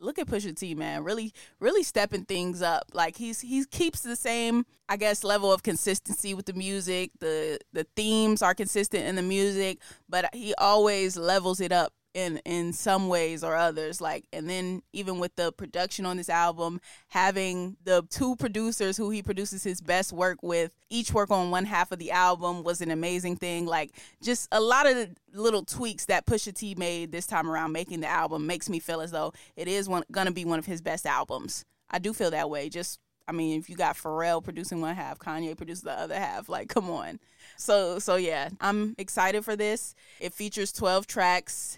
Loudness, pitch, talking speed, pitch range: -28 LUFS, 185 Hz, 205 wpm, 170-210 Hz